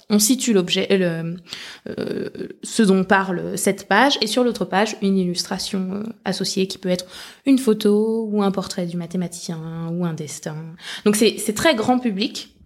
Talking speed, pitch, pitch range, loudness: 180 wpm, 195 Hz, 180-220 Hz, -20 LUFS